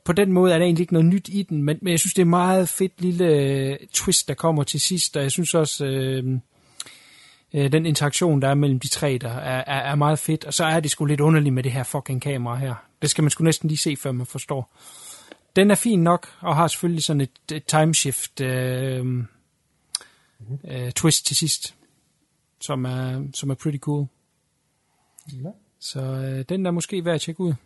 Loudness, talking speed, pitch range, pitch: -22 LUFS, 205 wpm, 135-170 Hz, 150 Hz